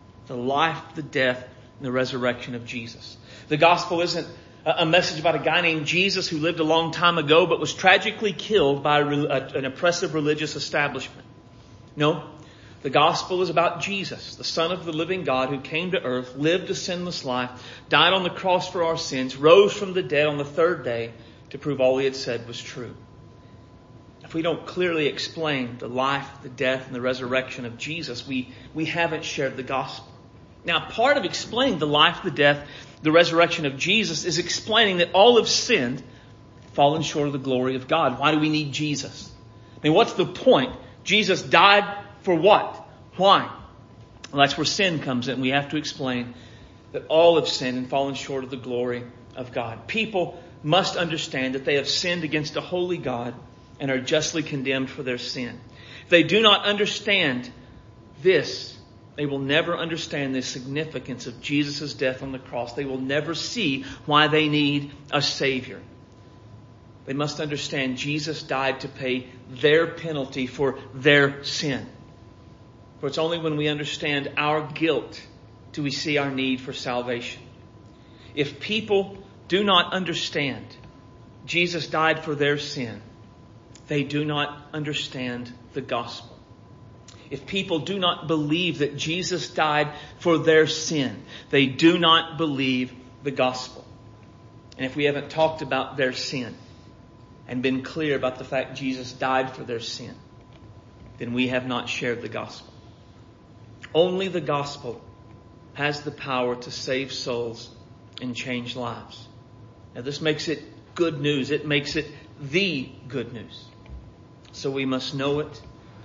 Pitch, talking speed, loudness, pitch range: 140 Hz, 165 wpm, -23 LUFS, 125-160 Hz